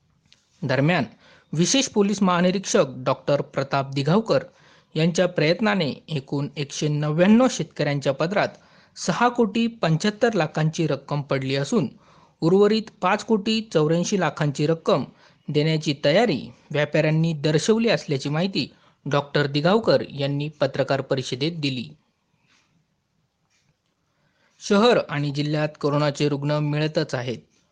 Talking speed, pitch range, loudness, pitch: 100 wpm, 145-180 Hz, -22 LUFS, 155 Hz